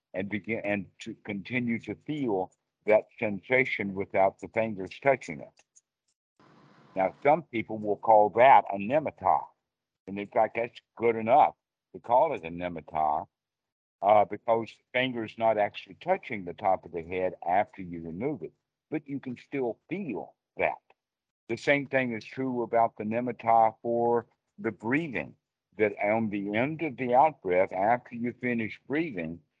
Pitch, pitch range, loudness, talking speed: 110 Hz, 100-120 Hz, -28 LUFS, 155 wpm